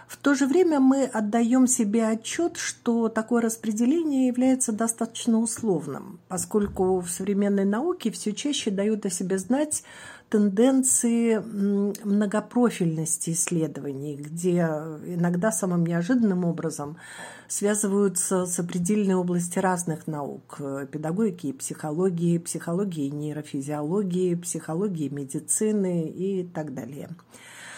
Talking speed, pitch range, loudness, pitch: 100 wpm, 165-225 Hz, -25 LUFS, 195 Hz